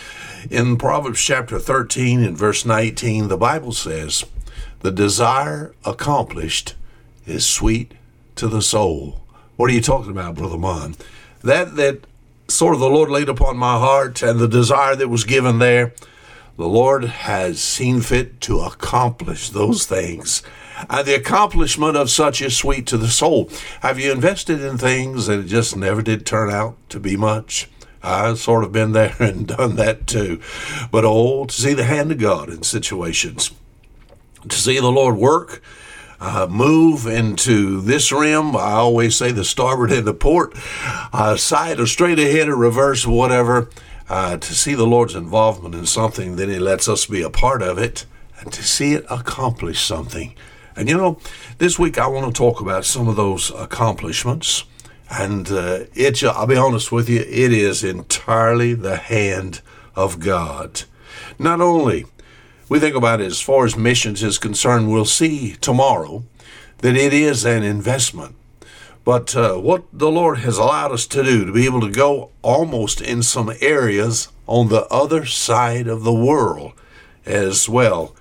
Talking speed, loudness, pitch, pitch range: 170 wpm, -17 LUFS, 120 Hz, 110-135 Hz